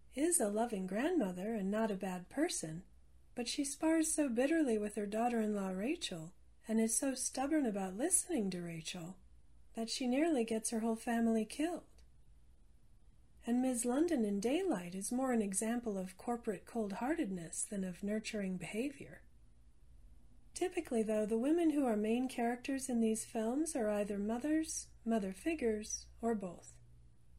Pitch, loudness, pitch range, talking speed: 225 Hz, -37 LUFS, 195-265 Hz, 155 wpm